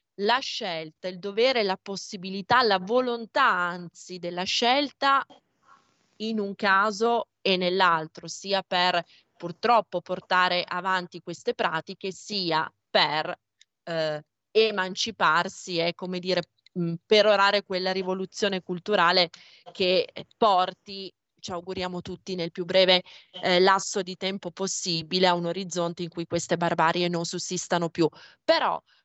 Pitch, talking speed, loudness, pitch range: 185 Hz, 120 wpm, -25 LUFS, 175-200 Hz